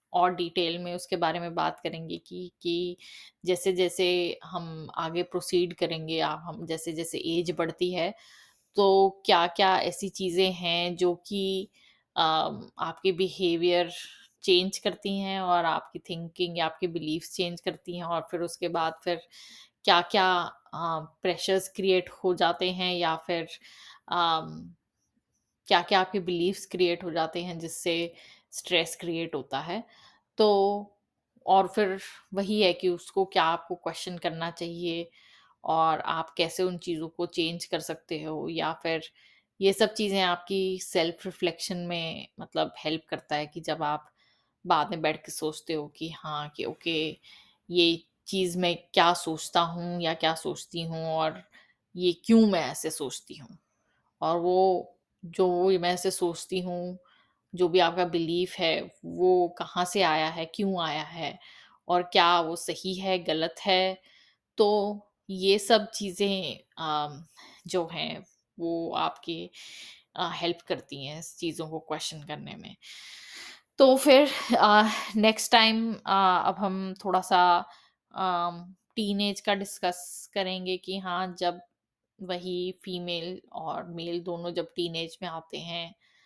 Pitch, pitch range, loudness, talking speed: 175 Hz, 165-190 Hz, -28 LUFS, 145 wpm